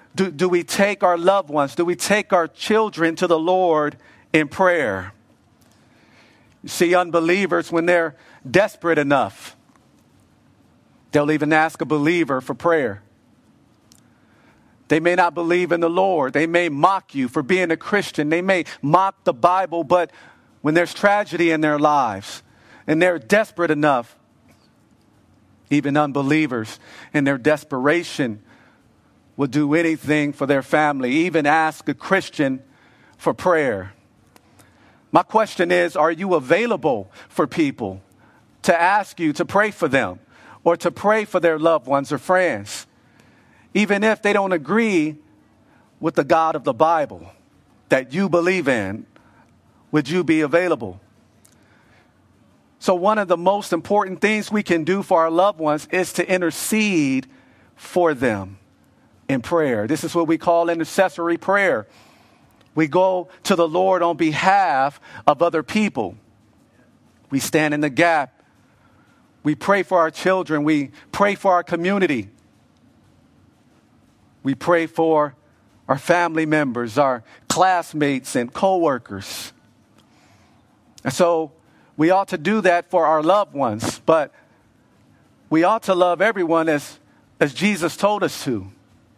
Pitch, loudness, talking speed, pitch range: 160 Hz, -19 LUFS, 140 wpm, 135-180 Hz